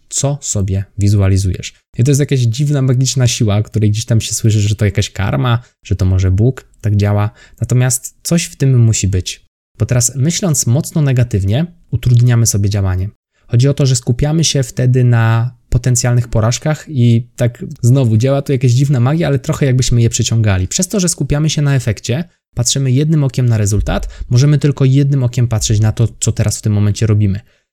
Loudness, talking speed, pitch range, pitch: -14 LUFS, 190 wpm, 110-140 Hz, 120 Hz